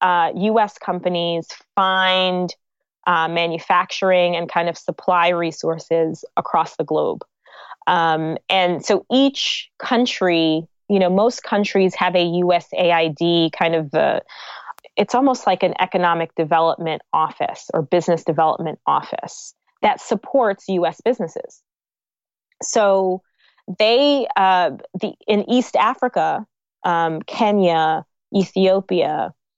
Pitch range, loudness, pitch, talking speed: 170-205 Hz, -19 LUFS, 180 Hz, 110 wpm